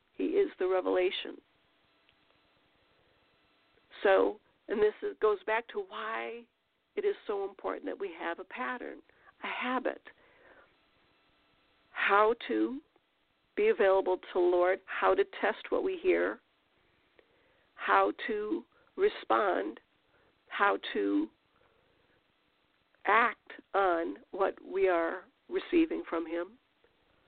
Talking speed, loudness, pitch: 105 wpm, -31 LUFS, 335 Hz